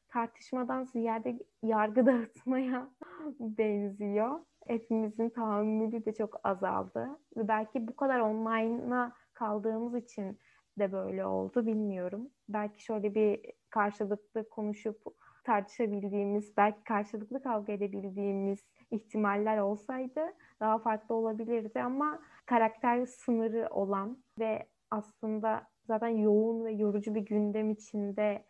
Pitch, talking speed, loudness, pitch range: 220 Hz, 105 wpm, -33 LUFS, 210-240 Hz